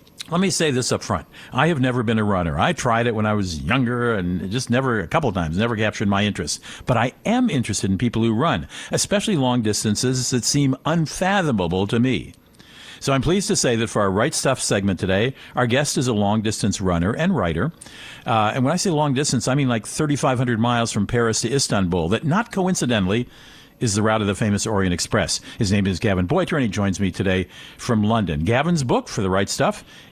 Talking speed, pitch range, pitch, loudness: 225 wpm, 105-135 Hz, 120 Hz, -21 LUFS